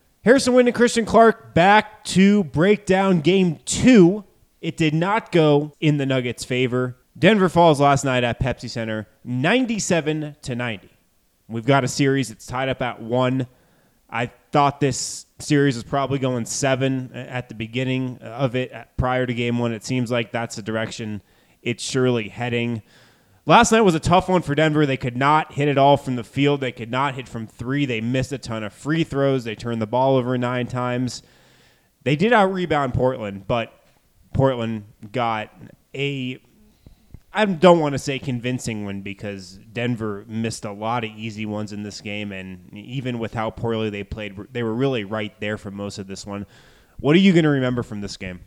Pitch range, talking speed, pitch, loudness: 110-145 Hz, 190 wpm, 125 Hz, -21 LUFS